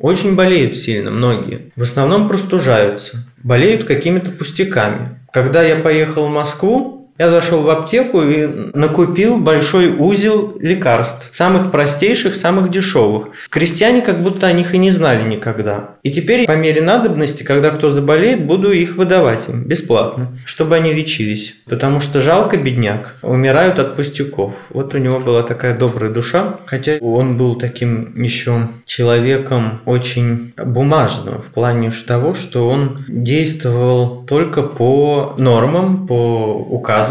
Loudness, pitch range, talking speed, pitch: -14 LUFS, 120-170 Hz, 140 wpm, 140 Hz